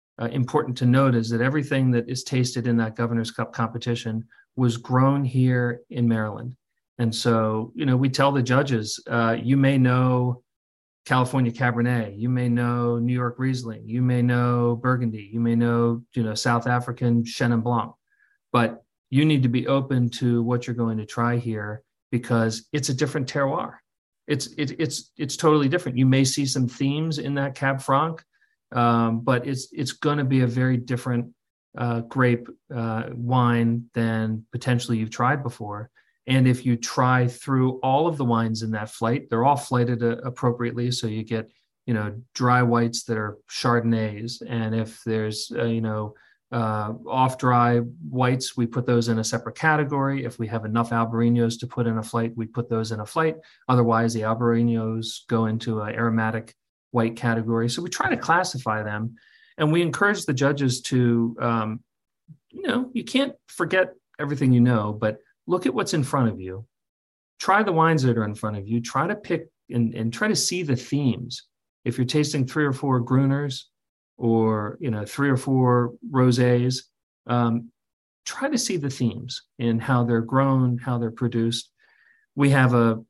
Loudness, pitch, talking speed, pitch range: -23 LUFS, 120 Hz, 180 wpm, 115-135 Hz